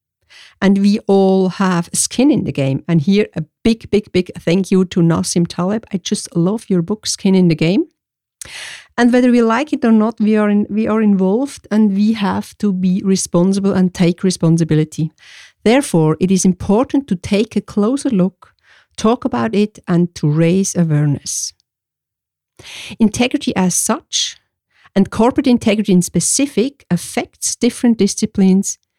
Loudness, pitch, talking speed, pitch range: -15 LUFS, 195 Hz, 160 wpm, 180-220 Hz